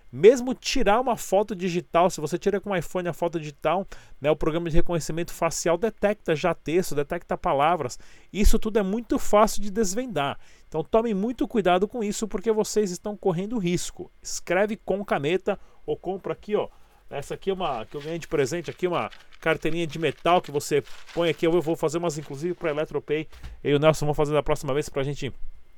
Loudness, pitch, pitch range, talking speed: -26 LUFS, 175 Hz, 155-205 Hz, 205 wpm